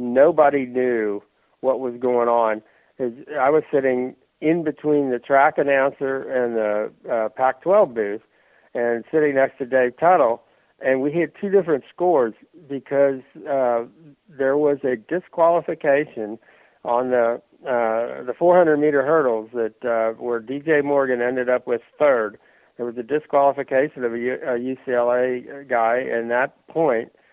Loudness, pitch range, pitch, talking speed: -21 LUFS, 120-145 Hz, 130 Hz, 140 wpm